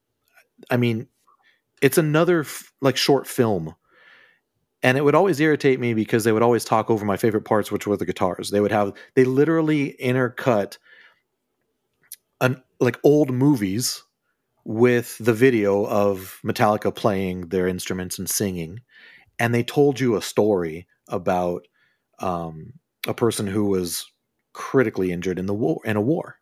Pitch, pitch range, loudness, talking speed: 115 Hz, 100-130 Hz, -21 LUFS, 150 wpm